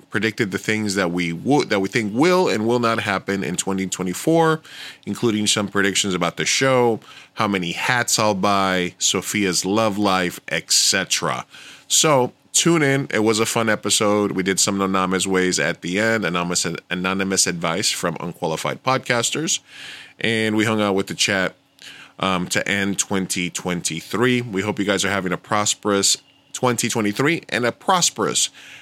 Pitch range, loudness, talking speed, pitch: 95-115 Hz, -20 LUFS, 160 wpm, 100 Hz